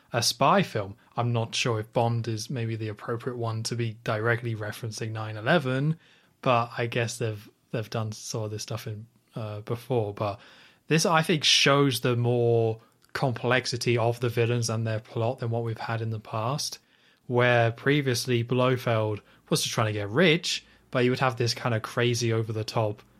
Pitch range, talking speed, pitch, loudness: 110-125 Hz, 185 wpm, 120 Hz, -27 LUFS